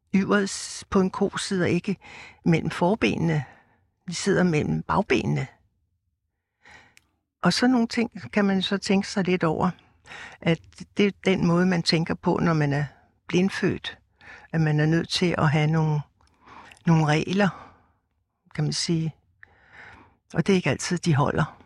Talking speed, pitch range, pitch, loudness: 150 wpm, 150-190 Hz, 170 Hz, -24 LUFS